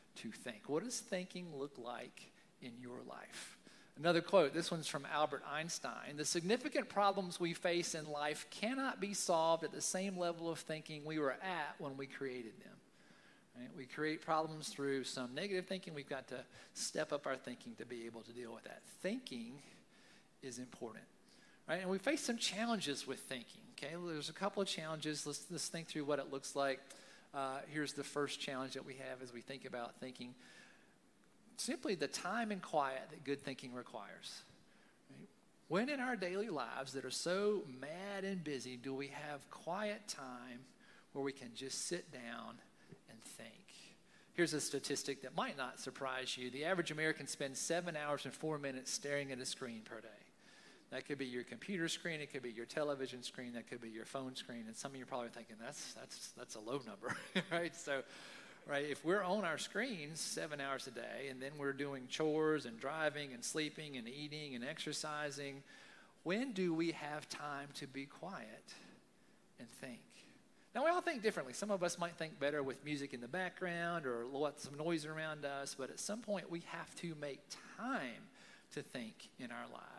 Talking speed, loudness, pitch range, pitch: 195 wpm, -42 LUFS, 135-170 Hz, 145 Hz